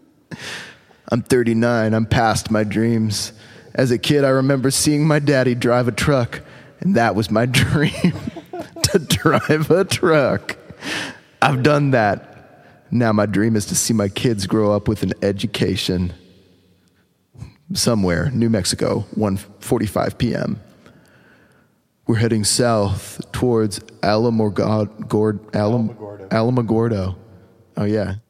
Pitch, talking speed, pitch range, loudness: 110 Hz, 115 wpm, 105-125 Hz, -18 LUFS